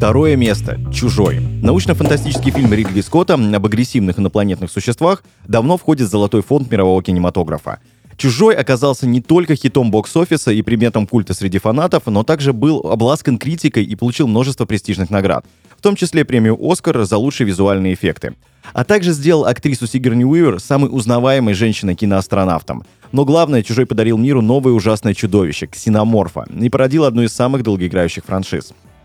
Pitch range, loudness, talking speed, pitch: 105-140 Hz, -14 LUFS, 150 wpm, 120 Hz